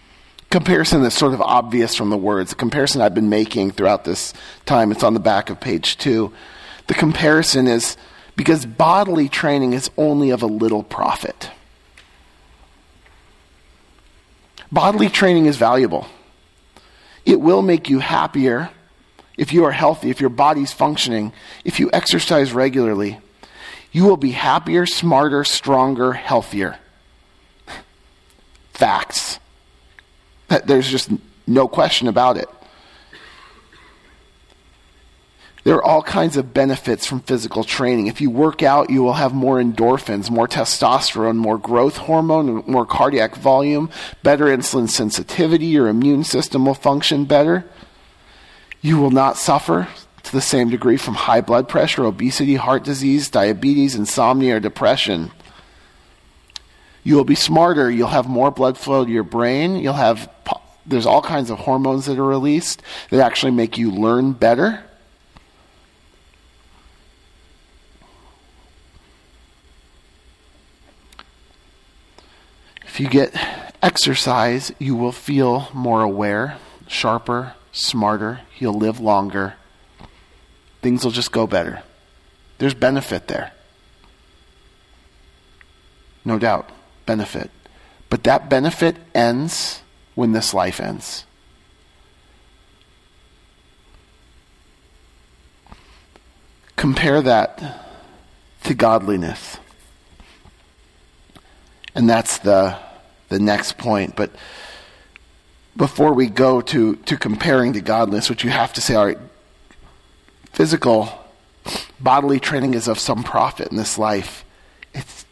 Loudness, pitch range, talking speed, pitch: -17 LUFS, 85-135 Hz, 115 wpm, 115 Hz